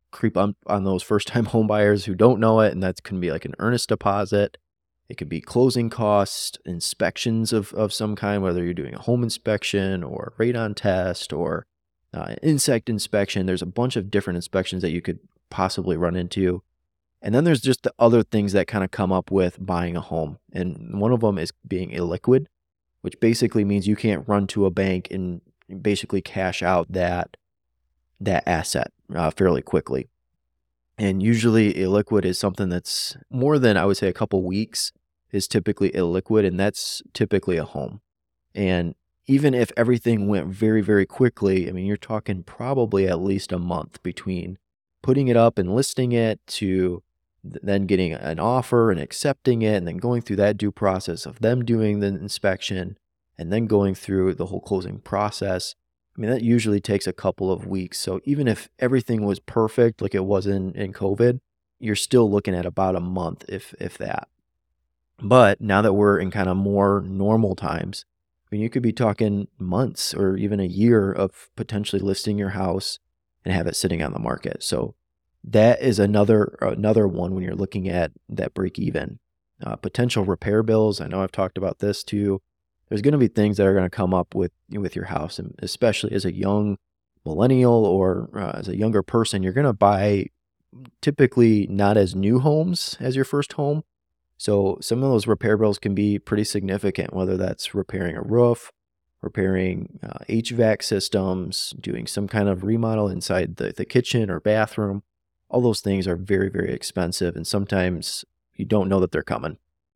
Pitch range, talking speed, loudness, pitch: 95-110 Hz, 190 wpm, -22 LUFS, 100 Hz